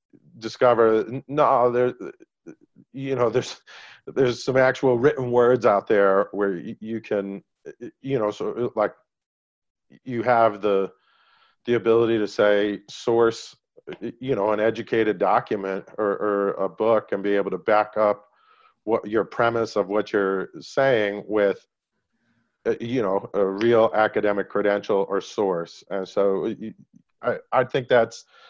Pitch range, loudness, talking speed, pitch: 100-120 Hz, -23 LUFS, 135 wpm, 110 Hz